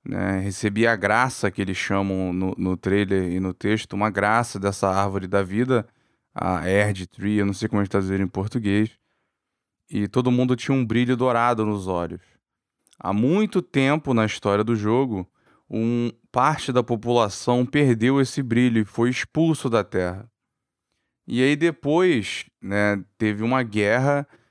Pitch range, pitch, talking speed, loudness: 100-125 Hz, 110 Hz, 160 wpm, -22 LUFS